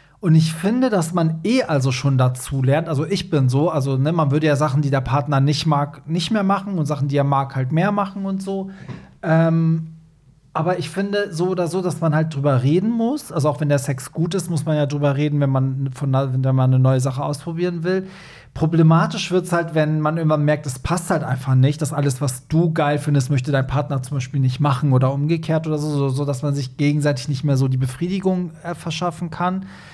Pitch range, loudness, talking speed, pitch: 140-170 Hz, -20 LUFS, 235 wpm, 150 Hz